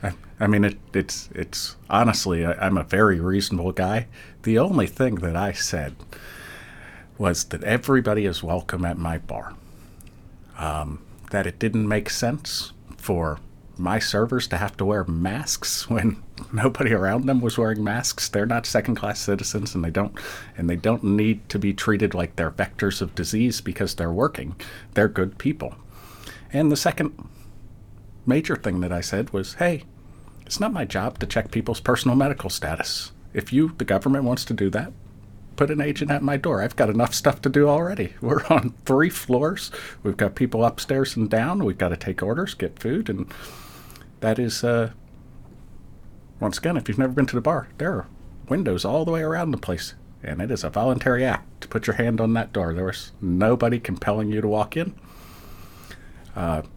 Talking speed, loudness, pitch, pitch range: 180 wpm, -24 LUFS, 105 Hz, 95-125 Hz